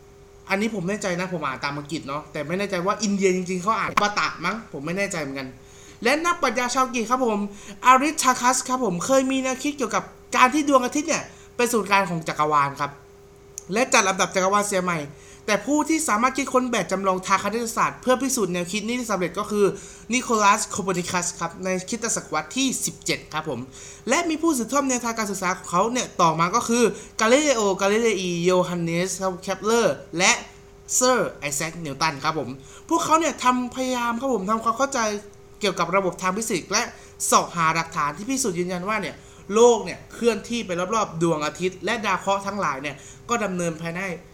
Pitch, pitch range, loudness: 200 Hz, 175-240 Hz, -23 LUFS